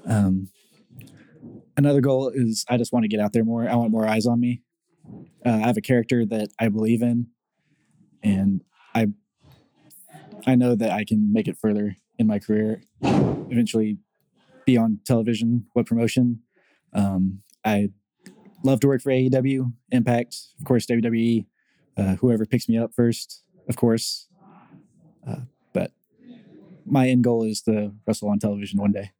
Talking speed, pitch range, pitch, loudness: 160 wpm, 110-130 Hz, 115 Hz, -23 LUFS